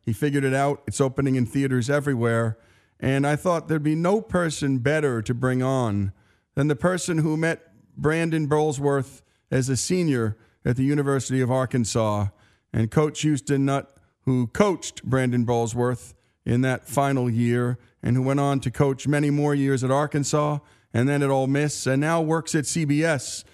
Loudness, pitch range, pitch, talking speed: -24 LUFS, 120-150 Hz, 135 Hz, 175 wpm